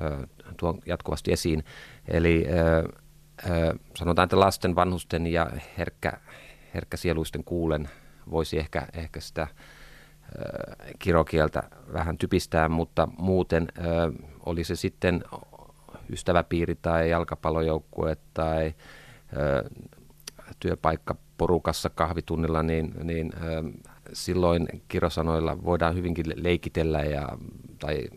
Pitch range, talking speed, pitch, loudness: 80-85 Hz, 95 wpm, 85 Hz, -27 LUFS